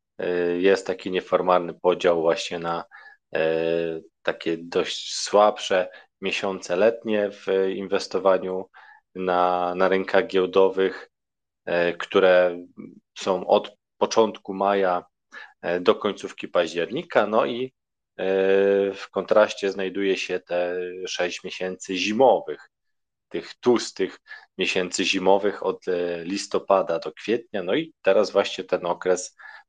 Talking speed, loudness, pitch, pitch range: 100 wpm, -23 LUFS, 95 Hz, 90-95 Hz